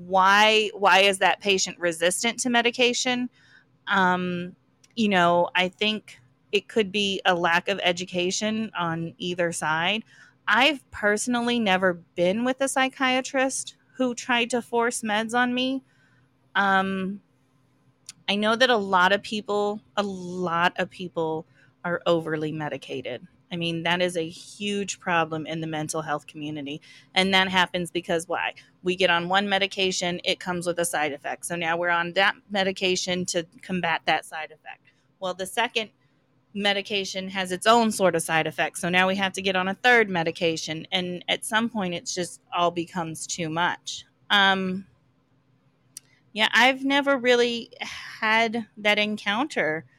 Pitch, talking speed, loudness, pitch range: 185 Hz, 155 wpm, -24 LUFS, 165-210 Hz